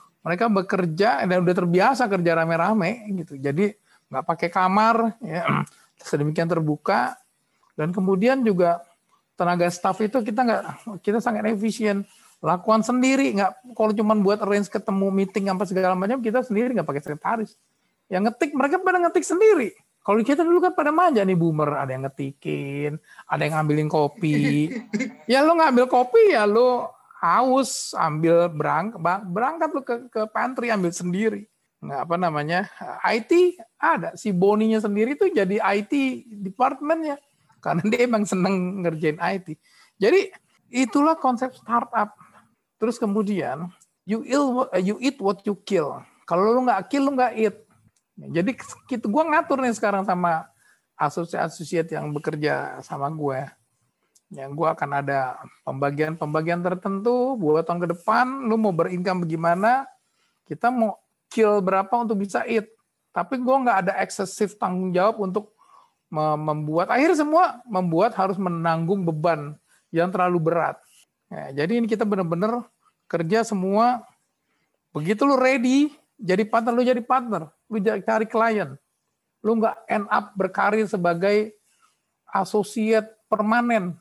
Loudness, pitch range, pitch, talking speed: -22 LUFS, 175-240 Hz, 210 Hz, 140 wpm